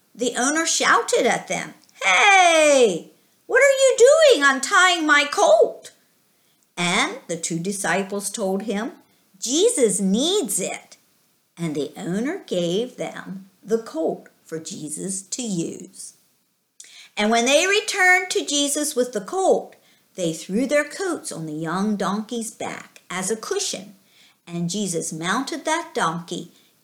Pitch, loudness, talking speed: 235 Hz, -20 LUFS, 130 wpm